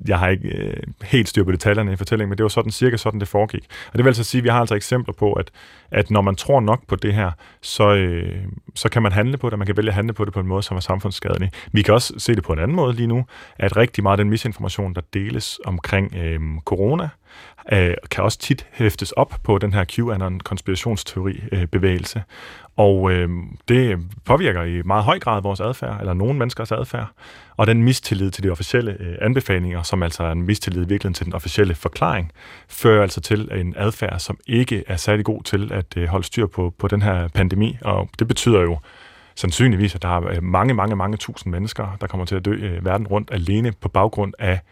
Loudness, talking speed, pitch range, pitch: -20 LUFS, 215 wpm, 95-110 Hz, 100 Hz